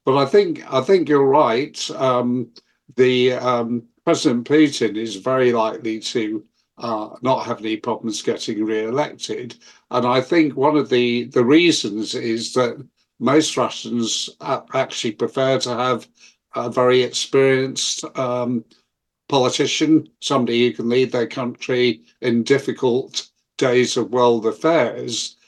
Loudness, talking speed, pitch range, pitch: -19 LUFS, 130 wpm, 115-135 Hz, 125 Hz